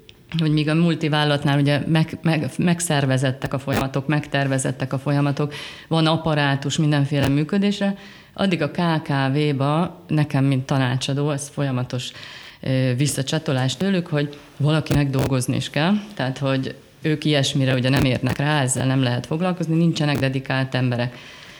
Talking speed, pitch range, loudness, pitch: 130 wpm, 135-155 Hz, -21 LUFS, 145 Hz